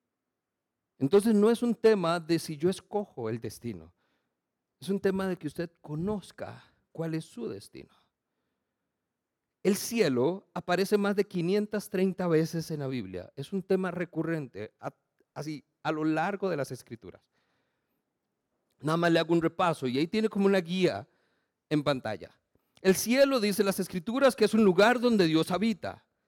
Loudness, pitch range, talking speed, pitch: -28 LUFS, 155-205 Hz, 160 wpm, 180 Hz